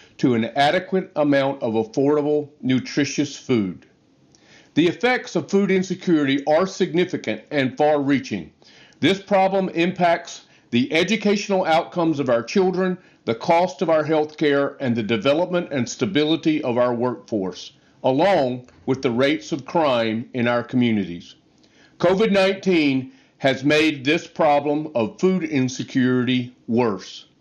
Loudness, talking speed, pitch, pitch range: -21 LUFS, 130 wpm, 150 Hz, 130-180 Hz